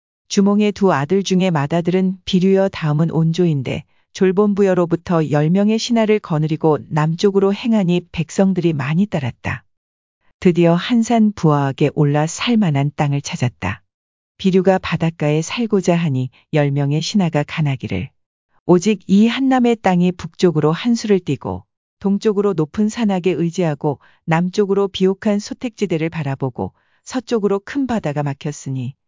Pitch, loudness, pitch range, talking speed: 175 Hz, -17 LUFS, 145-200 Hz, 320 characters per minute